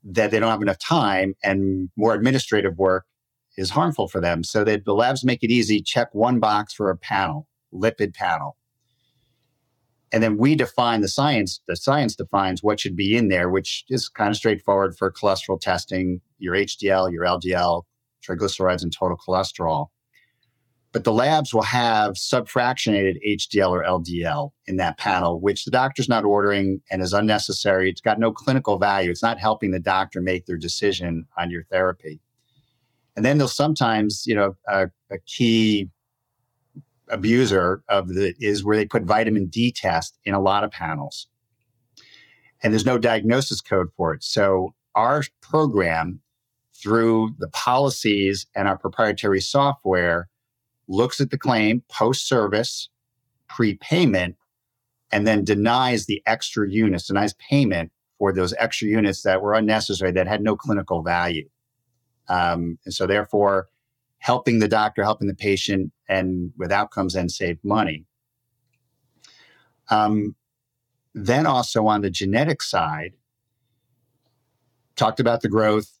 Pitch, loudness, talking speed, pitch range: 110 Hz, -21 LUFS, 150 wpm, 95-125 Hz